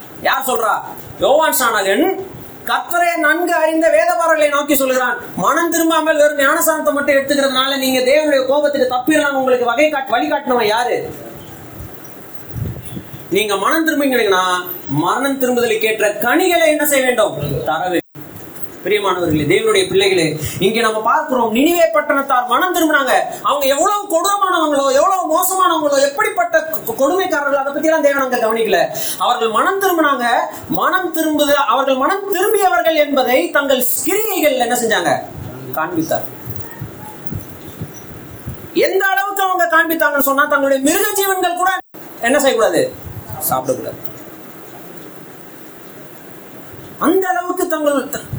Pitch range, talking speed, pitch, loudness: 270-345 Hz, 110 wpm, 295 Hz, -15 LUFS